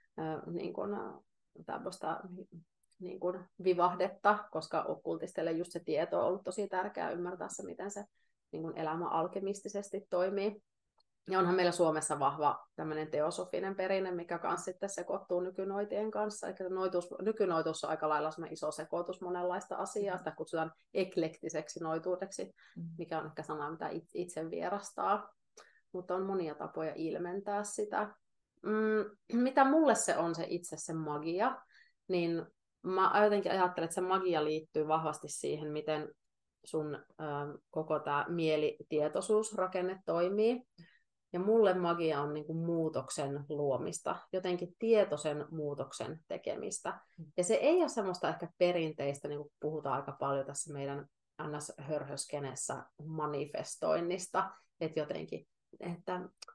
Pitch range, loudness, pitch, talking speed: 155-190 Hz, -36 LUFS, 175 Hz, 125 wpm